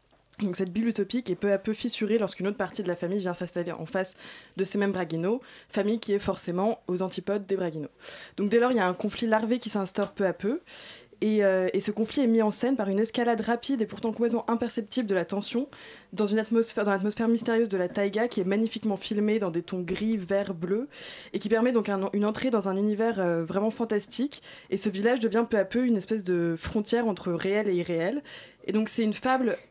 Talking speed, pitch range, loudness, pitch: 235 wpm, 195-230 Hz, -28 LUFS, 210 Hz